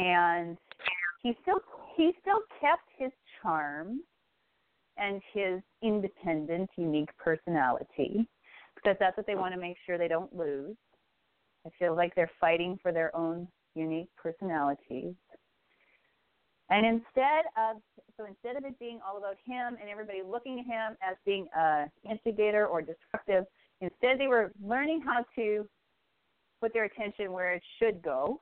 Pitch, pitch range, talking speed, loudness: 200 Hz, 170-230 Hz, 145 wpm, -32 LUFS